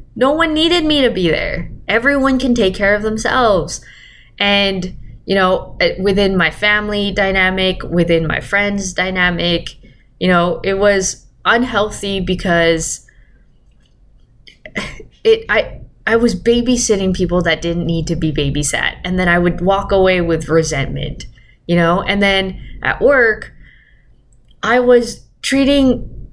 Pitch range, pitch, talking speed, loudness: 170-220 Hz, 190 Hz, 135 wpm, -15 LUFS